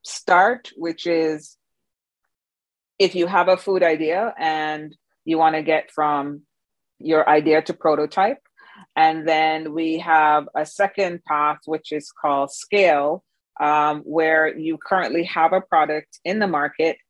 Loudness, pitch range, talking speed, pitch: -20 LUFS, 150-165 Hz, 140 wpm, 155 Hz